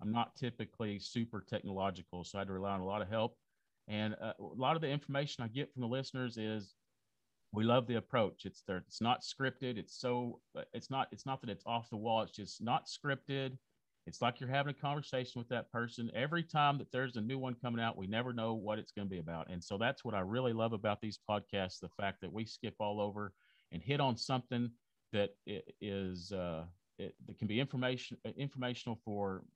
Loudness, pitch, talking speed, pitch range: -39 LUFS, 115 Hz, 220 wpm, 100-125 Hz